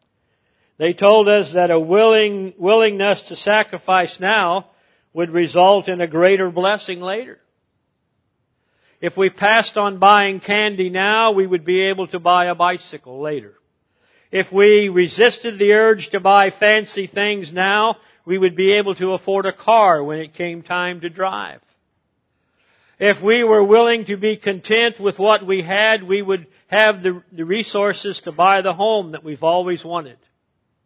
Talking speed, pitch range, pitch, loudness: 160 wpm, 180-210 Hz, 195 Hz, -16 LUFS